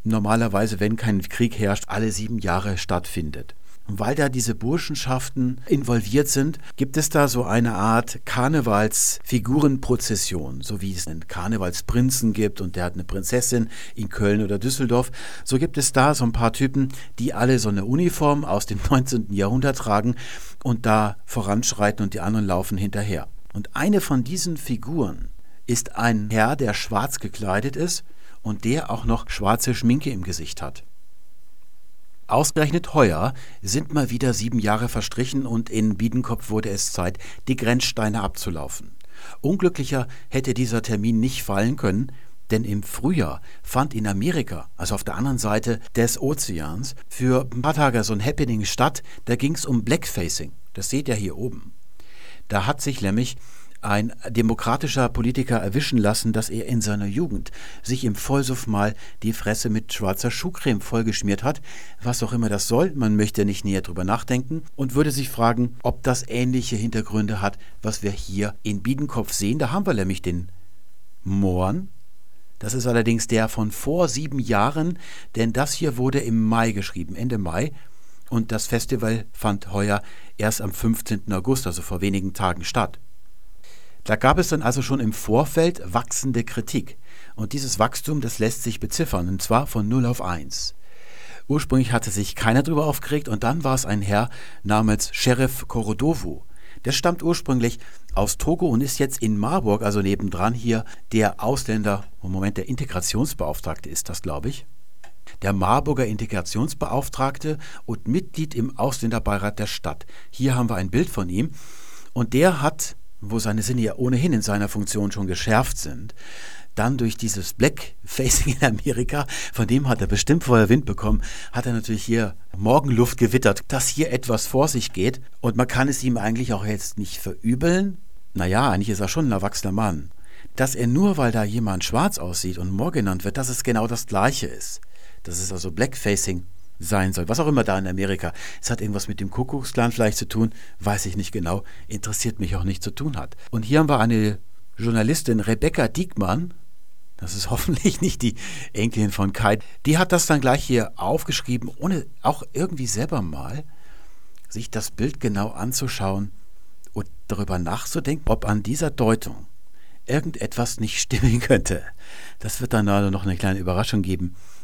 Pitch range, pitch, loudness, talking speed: 100-130 Hz, 115 Hz, -23 LUFS, 170 wpm